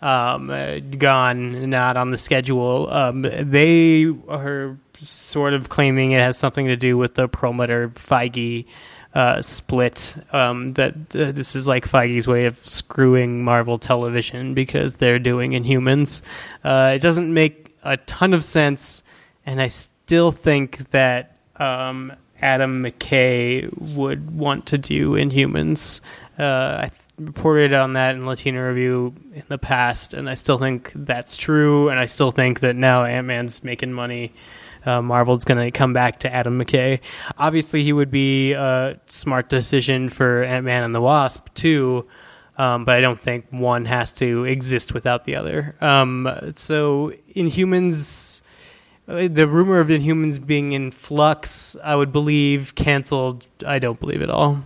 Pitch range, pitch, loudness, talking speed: 125-145 Hz, 130 Hz, -19 LUFS, 155 wpm